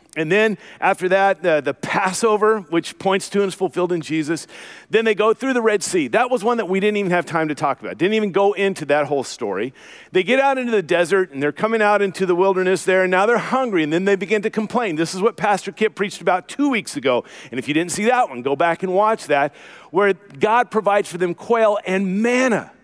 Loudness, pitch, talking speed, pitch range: -19 LUFS, 195 Hz, 250 wpm, 175-220 Hz